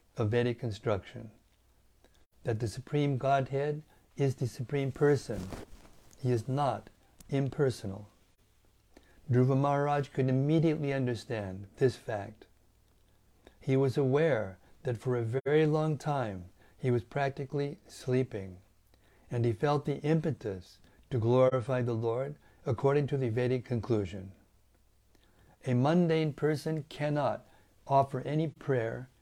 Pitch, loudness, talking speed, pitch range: 125 Hz, -31 LUFS, 115 wpm, 105-140 Hz